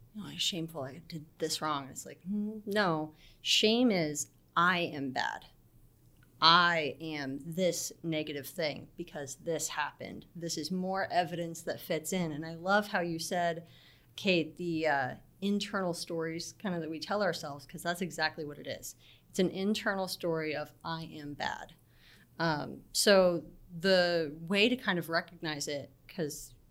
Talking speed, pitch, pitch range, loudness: 160 wpm, 165 Hz, 155-185 Hz, -32 LUFS